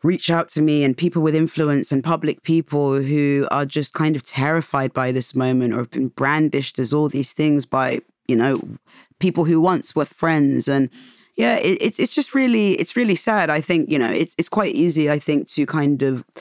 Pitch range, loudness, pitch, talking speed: 140-165 Hz, -19 LUFS, 150 Hz, 215 wpm